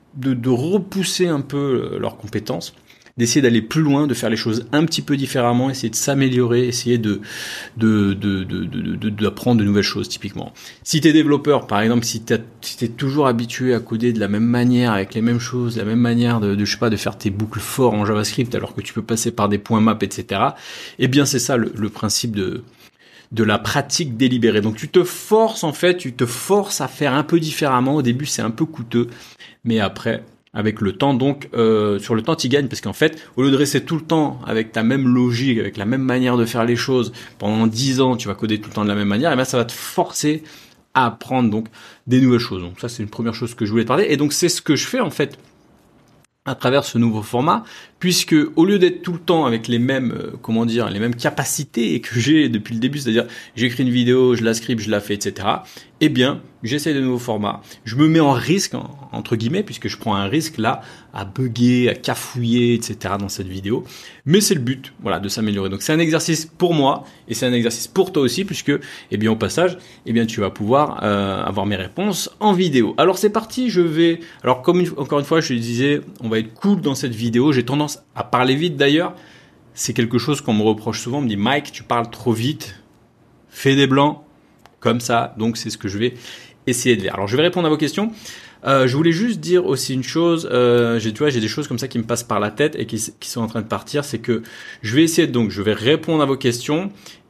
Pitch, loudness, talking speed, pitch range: 125 Hz, -19 LUFS, 245 wpm, 110-145 Hz